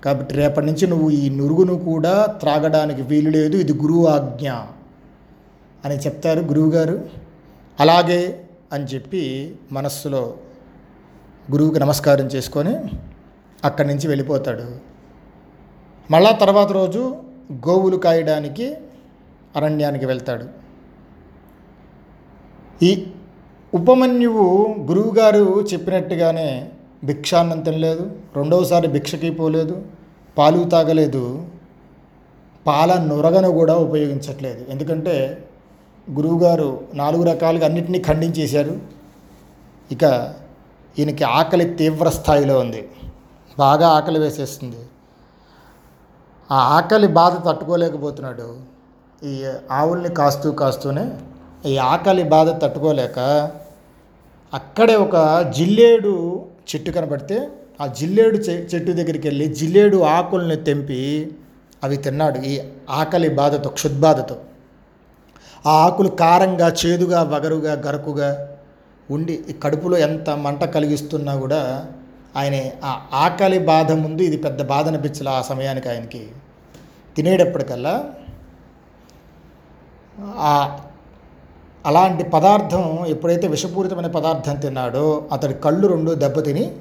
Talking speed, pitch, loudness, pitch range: 90 wpm, 155 Hz, -18 LUFS, 140-175 Hz